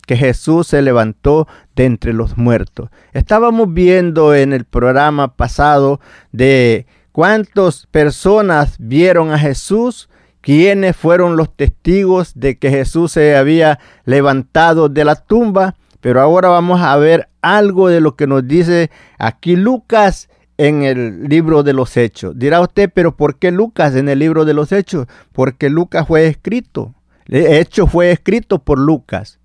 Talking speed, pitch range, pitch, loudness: 150 wpm, 135-175 Hz, 150 Hz, -12 LUFS